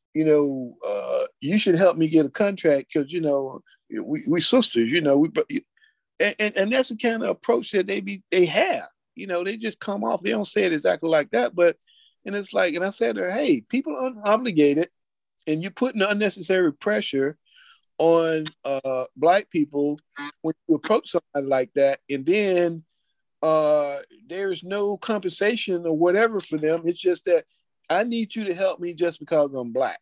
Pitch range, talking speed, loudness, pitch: 155-220 Hz, 190 wpm, -23 LUFS, 185 Hz